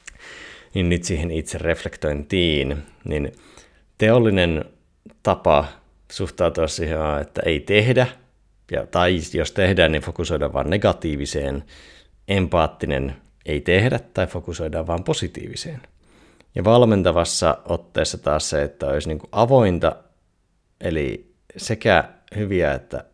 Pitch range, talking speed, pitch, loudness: 75-95 Hz, 100 wpm, 85 Hz, -21 LUFS